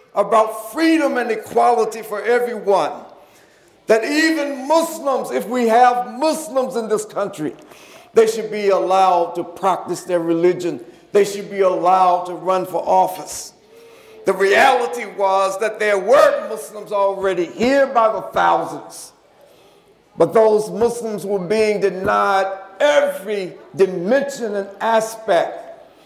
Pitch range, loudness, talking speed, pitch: 195-245 Hz, -18 LUFS, 125 wpm, 215 Hz